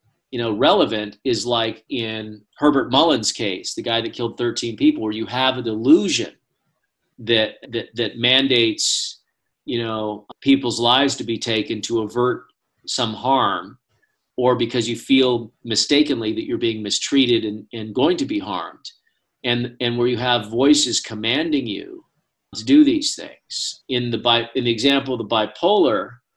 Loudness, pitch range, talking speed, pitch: -20 LUFS, 115-135 Hz, 160 wpm, 120 Hz